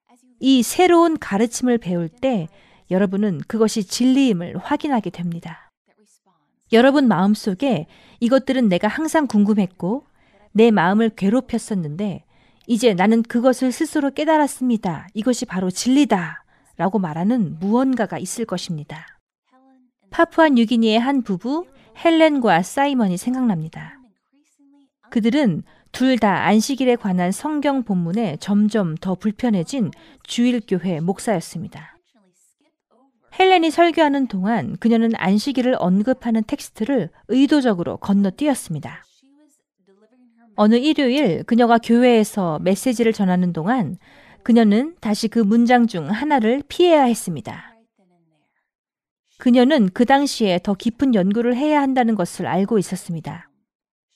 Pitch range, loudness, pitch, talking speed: 195-260 Hz, -19 LUFS, 230 Hz, 285 characters per minute